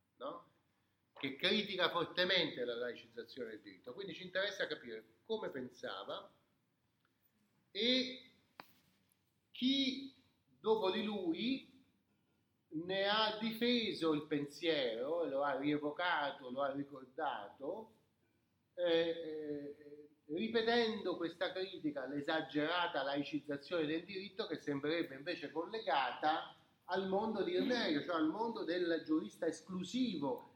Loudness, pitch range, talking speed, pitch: -38 LUFS, 150-220 Hz, 100 wpm, 175 Hz